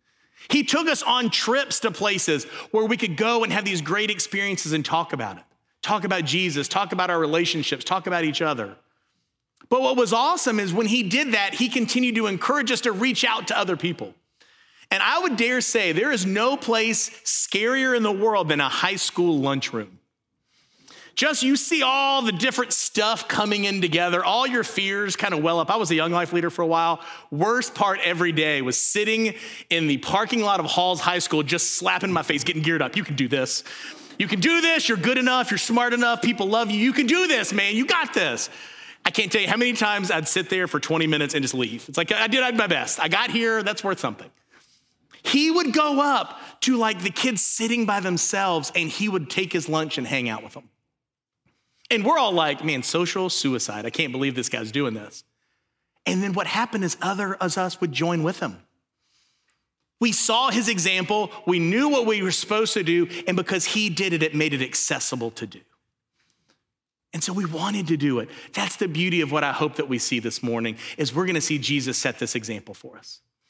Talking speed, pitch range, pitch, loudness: 220 wpm, 160-230 Hz, 195 Hz, -22 LUFS